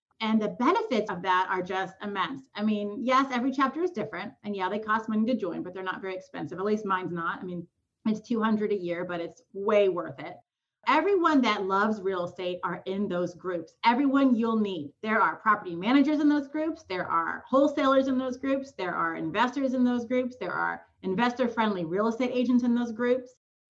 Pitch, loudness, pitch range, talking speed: 215 Hz, -28 LUFS, 185-255 Hz, 210 wpm